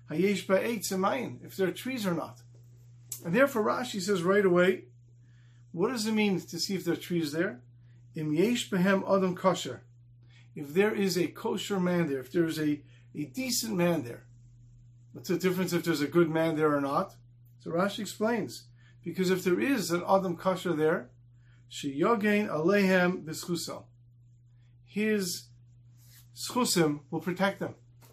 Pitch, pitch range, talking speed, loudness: 170 Hz, 120-190 Hz, 140 wpm, -29 LUFS